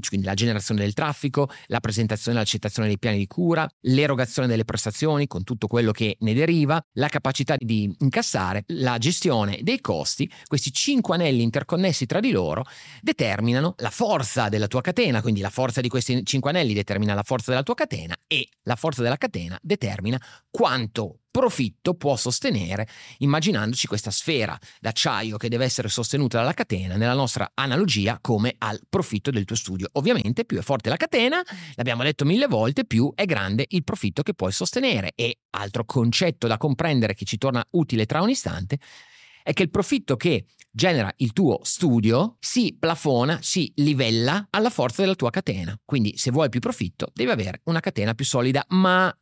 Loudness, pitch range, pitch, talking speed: -23 LUFS, 110-160 Hz, 130 Hz, 175 wpm